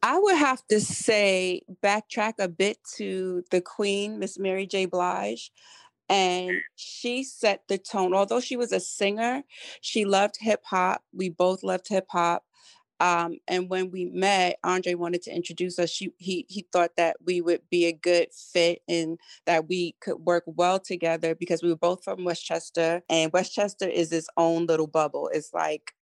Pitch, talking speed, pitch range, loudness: 185 Hz, 175 wpm, 175-200 Hz, -26 LUFS